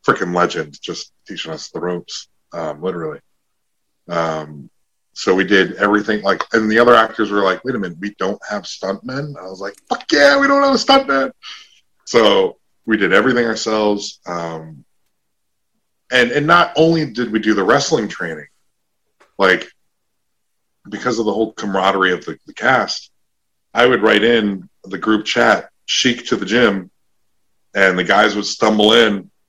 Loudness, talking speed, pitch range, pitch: -16 LUFS, 165 wpm, 95-125 Hz, 110 Hz